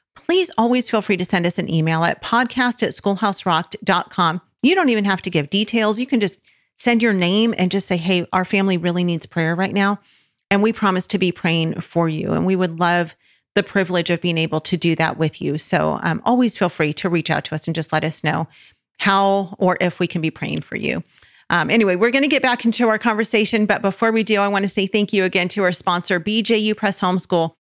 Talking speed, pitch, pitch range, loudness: 240 wpm, 190 Hz, 175-215 Hz, -19 LUFS